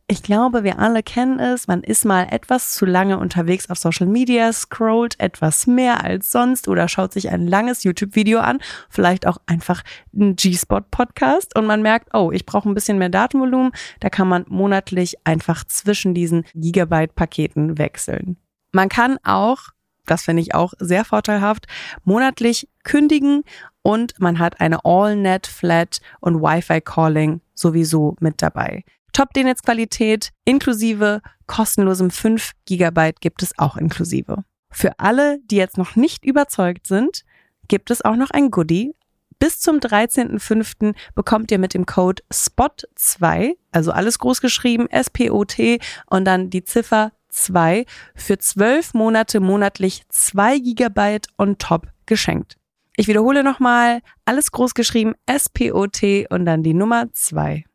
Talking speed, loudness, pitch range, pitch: 145 wpm, -18 LUFS, 180-240 Hz, 205 Hz